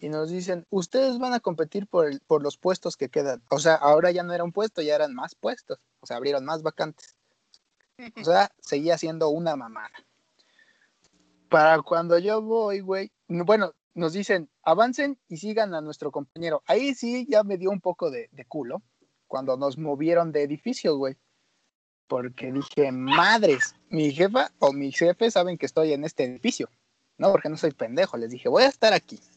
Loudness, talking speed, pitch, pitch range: -25 LUFS, 190 wpm, 170 Hz, 150-215 Hz